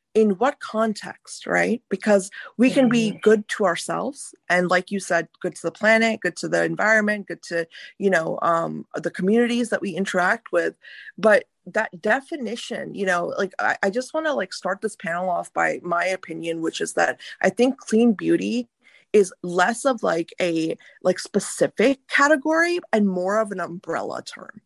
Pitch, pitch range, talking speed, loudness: 205 Hz, 180-235 Hz, 180 wpm, -22 LUFS